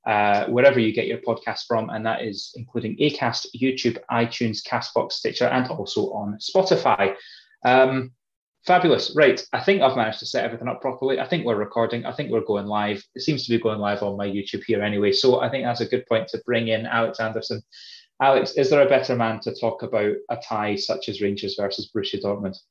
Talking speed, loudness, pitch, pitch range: 215 wpm, -22 LUFS, 115 Hz, 105-125 Hz